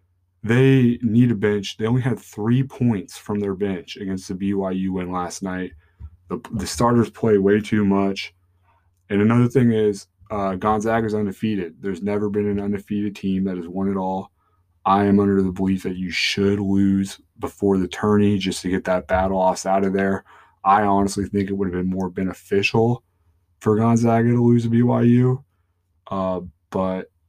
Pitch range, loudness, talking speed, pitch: 95-105 Hz, -21 LUFS, 180 wpm, 100 Hz